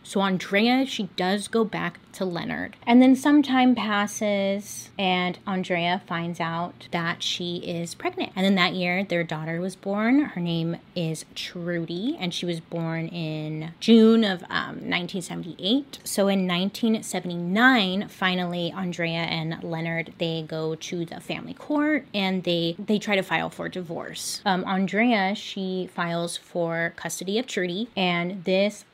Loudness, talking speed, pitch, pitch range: -25 LUFS, 155 wpm, 185 Hz, 170-210 Hz